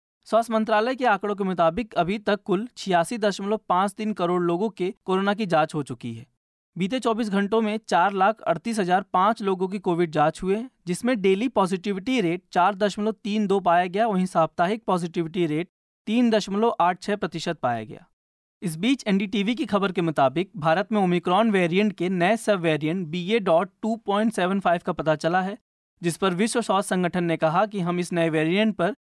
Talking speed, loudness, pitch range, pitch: 180 wpm, -24 LUFS, 175-215 Hz, 195 Hz